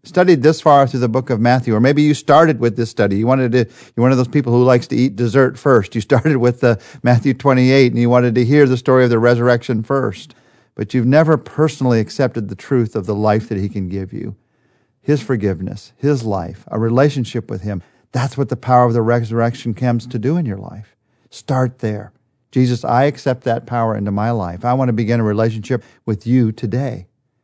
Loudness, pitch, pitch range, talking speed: -16 LUFS, 125 Hz, 115-130 Hz, 220 wpm